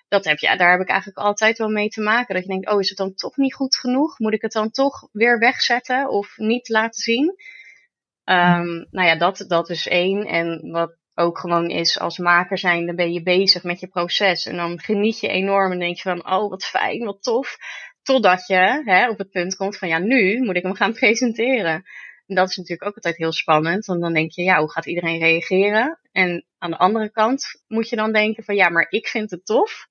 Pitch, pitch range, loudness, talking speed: 195 Hz, 175-220 Hz, -19 LUFS, 235 wpm